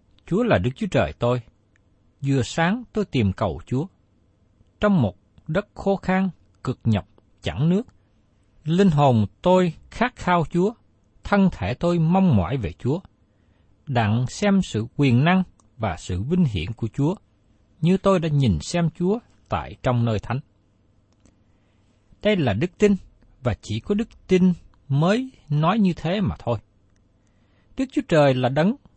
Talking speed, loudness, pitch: 155 wpm, -22 LUFS, 120 Hz